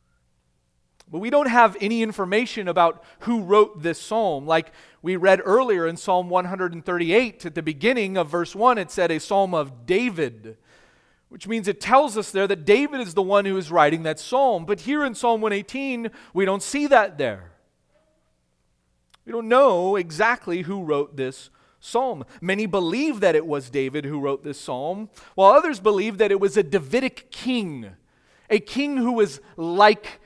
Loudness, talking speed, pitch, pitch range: -22 LUFS, 175 wpm, 195 Hz, 160-225 Hz